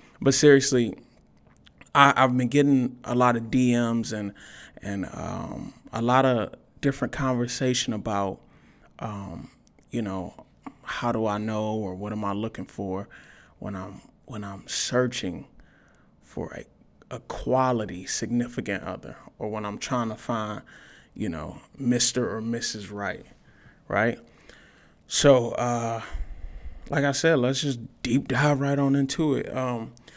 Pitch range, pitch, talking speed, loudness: 105-130 Hz, 120 Hz, 140 wpm, -25 LUFS